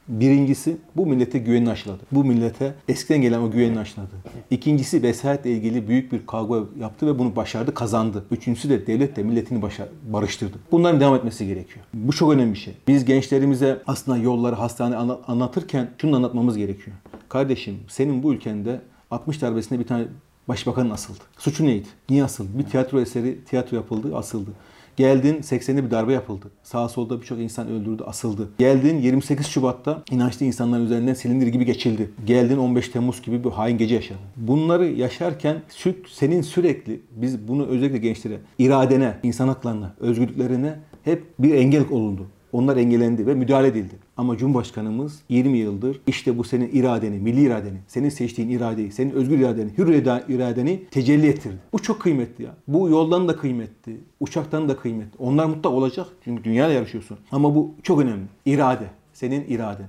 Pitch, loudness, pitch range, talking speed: 125 Hz, -22 LUFS, 115-140 Hz, 165 wpm